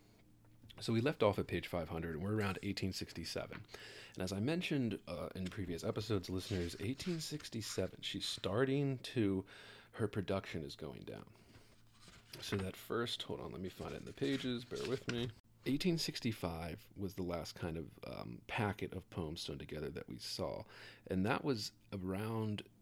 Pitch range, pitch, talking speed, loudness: 95-115 Hz, 105 Hz, 165 wpm, -41 LUFS